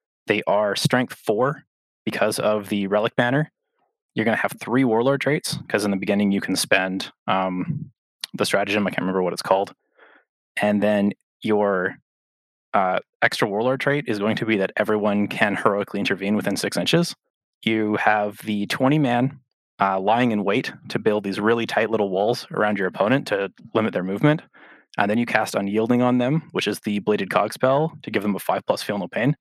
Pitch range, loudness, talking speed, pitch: 100-130 Hz, -22 LUFS, 195 wpm, 105 Hz